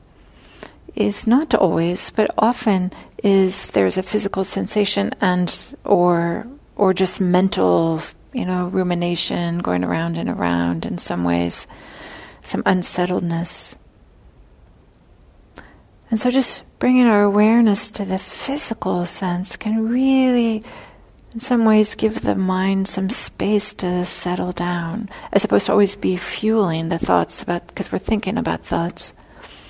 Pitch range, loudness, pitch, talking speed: 170-215 Hz, -19 LUFS, 190 Hz, 130 wpm